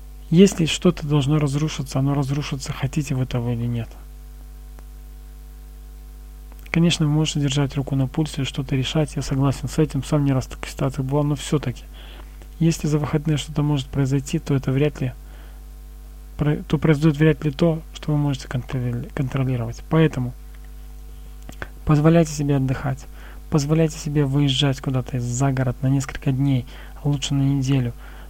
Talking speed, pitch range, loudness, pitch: 145 wpm, 120-150 Hz, -22 LUFS, 140 Hz